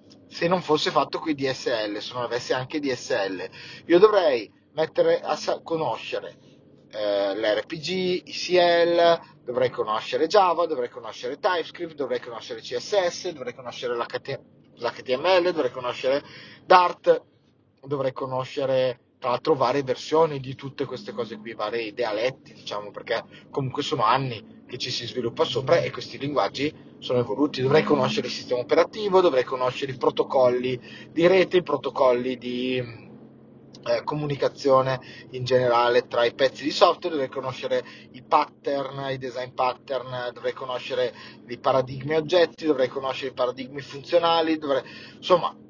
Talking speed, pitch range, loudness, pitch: 140 wpm, 125-175 Hz, -24 LUFS, 140 Hz